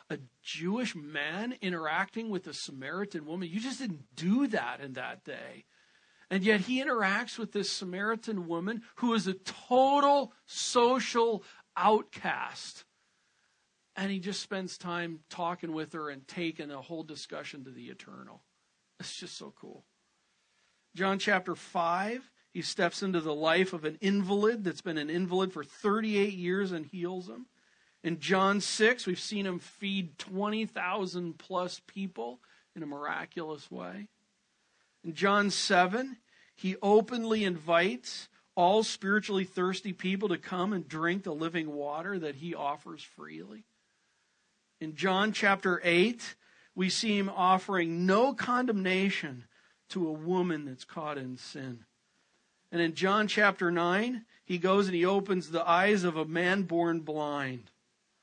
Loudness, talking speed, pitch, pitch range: -31 LUFS, 145 wpm, 185 Hz, 165-205 Hz